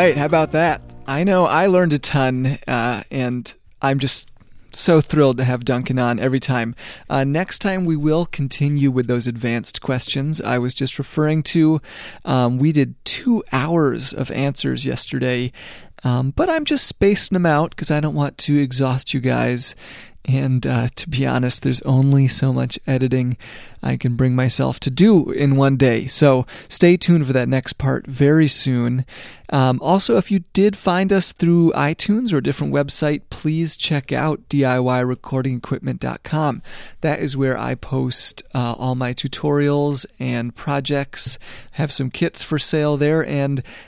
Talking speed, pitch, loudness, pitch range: 170 wpm, 135 Hz, -18 LUFS, 125-155 Hz